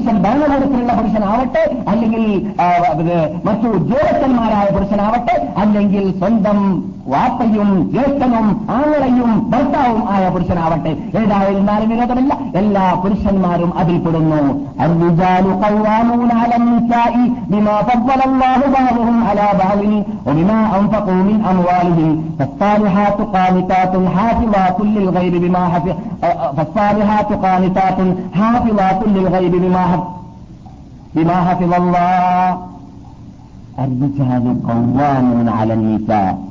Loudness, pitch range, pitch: -14 LUFS, 180-225 Hz, 200 Hz